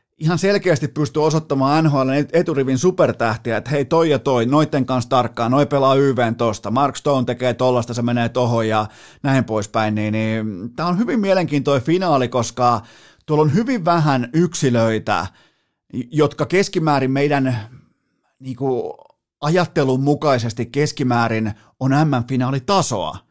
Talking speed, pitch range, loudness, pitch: 135 wpm, 120-150 Hz, -18 LUFS, 135 Hz